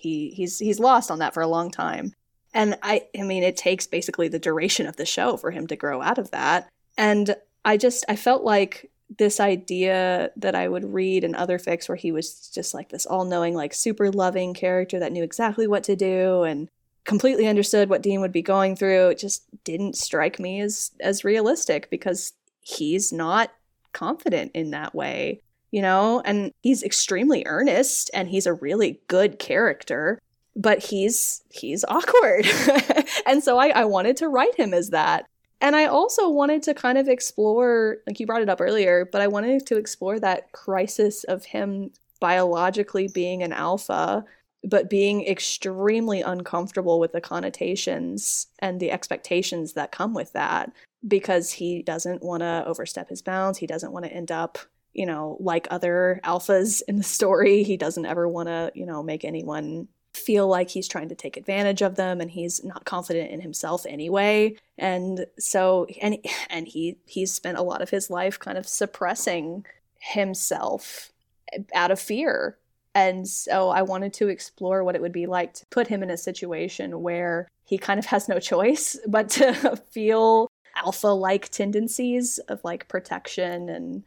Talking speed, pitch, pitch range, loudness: 180 wpm, 190 Hz, 175-215 Hz, -23 LUFS